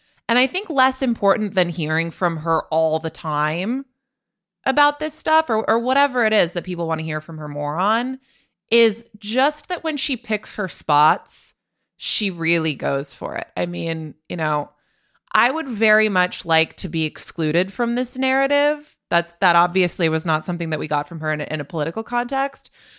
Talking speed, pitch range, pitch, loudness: 195 wpm, 160-255 Hz, 185 Hz, -20 LUFS